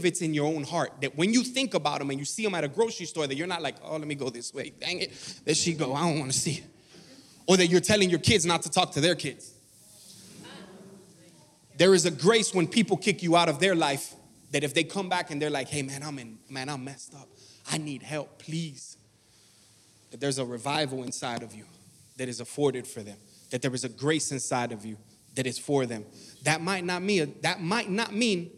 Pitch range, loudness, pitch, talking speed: 130-175 Hz, -27 LUFS, 150 Hz, 245 wpm